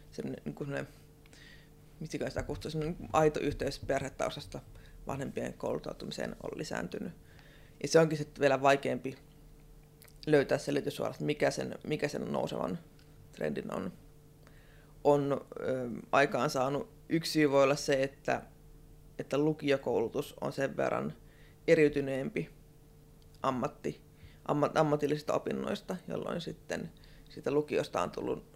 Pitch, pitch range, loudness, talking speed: 150 Hz, 140-150 Hz, -33 LUFS, 115 wpm